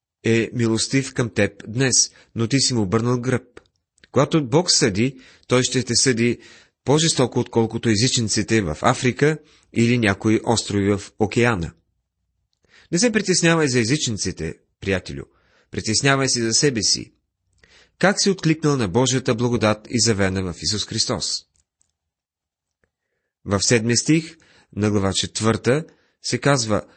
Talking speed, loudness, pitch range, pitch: 130 wpm, -20 LUFS, 100-130 Hz, 115 Hz